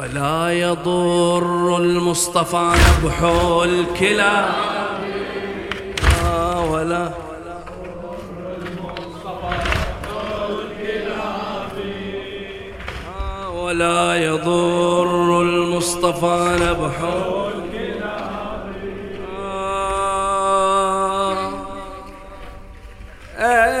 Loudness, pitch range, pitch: -19 LUFS, 170-195 Hz, 175 Hz